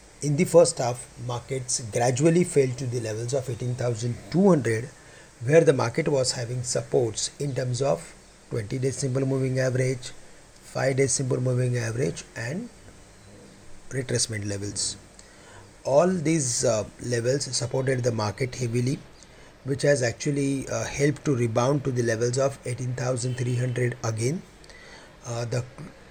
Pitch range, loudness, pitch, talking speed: 120-140 Hz, -25 LUFS, 125 Hz, 130 wpm